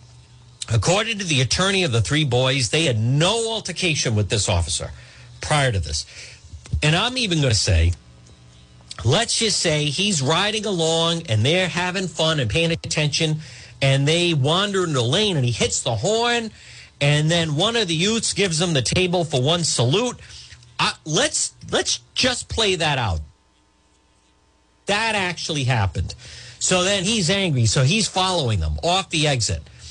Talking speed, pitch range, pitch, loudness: 165 wpm, 115-180 Hz, 150 Hz, -20 LUFS